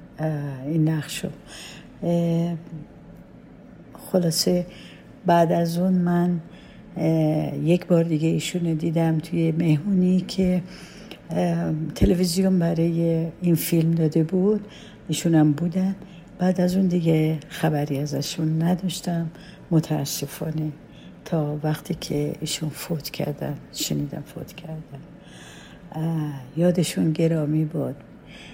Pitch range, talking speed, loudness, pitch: 155-180 Hz, 95 wpm, -23 LUFS, 165 Hz